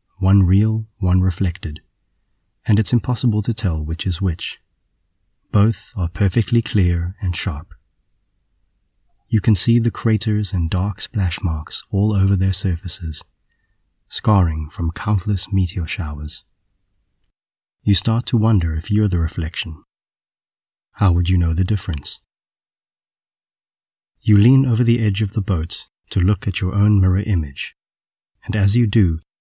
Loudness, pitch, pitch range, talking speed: -19 LUFS, 95 Hz, 90-105 Hz, 140 wpm